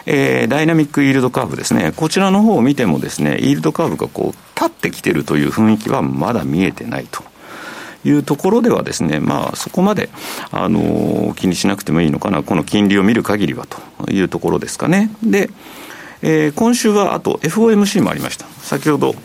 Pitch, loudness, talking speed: 165 Hz, -16 LUFS, 420 characters per minute